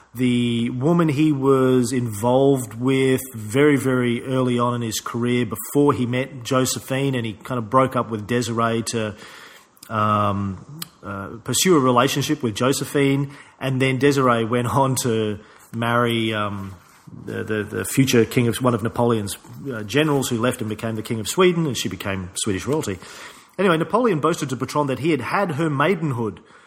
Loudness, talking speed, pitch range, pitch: -21 LUFS, 170 wpm, 115-140 Hz, 125 Hz